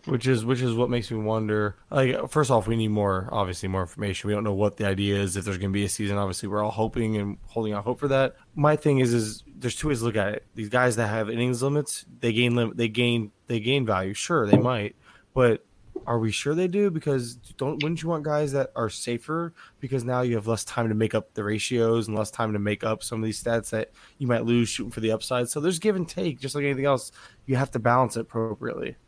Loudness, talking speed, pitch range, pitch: -26 LUFS, 265 wpm, 105-130 Hz, 115 Hz